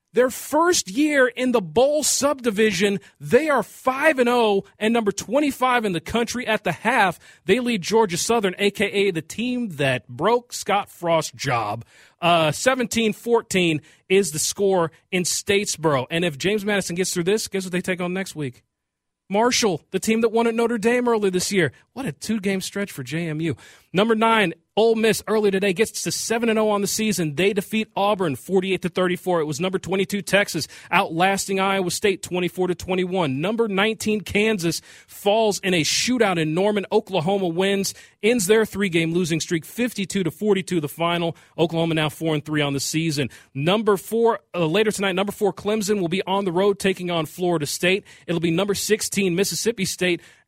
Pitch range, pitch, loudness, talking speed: 170-220 Hz, 195 Hz, -21 LUFS, 175 wpm